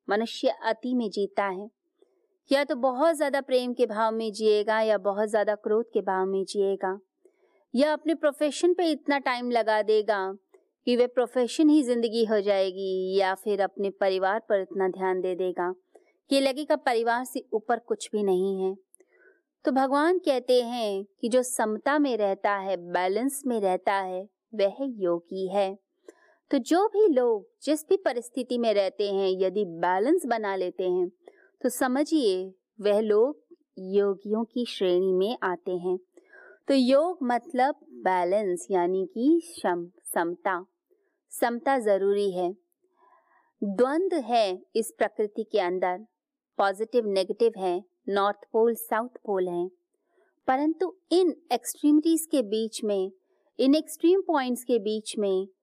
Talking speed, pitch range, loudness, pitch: 145 wpm, 195-290 Hz, -26 LUFS, 225 Hz